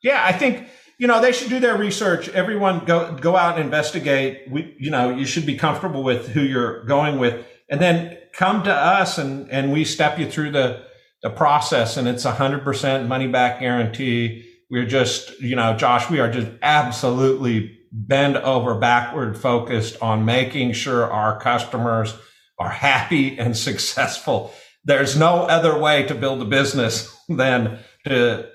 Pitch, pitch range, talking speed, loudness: 135 Hz, 120-155 Hz, 170 wpm, -19 LUFS